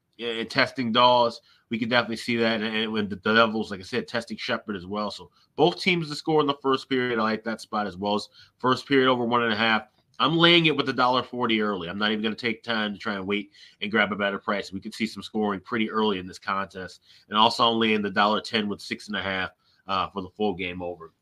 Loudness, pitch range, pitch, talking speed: -25 LUFS, 105-120 Hz, 110 Hz, 265 wpm